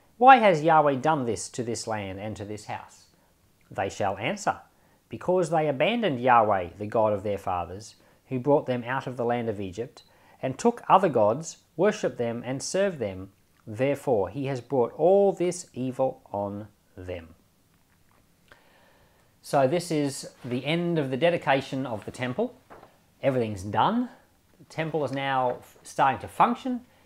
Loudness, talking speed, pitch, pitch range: -26 LUFS, 155 wpm, 130 Hz, 110-160 Hz